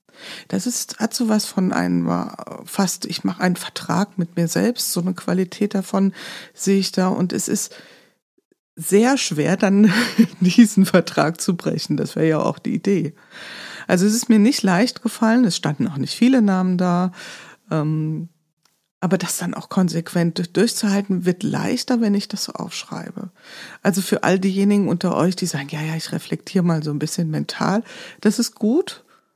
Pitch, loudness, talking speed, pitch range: 195 Hz, -20 LUFS, 175 wpm, 175-220 Hz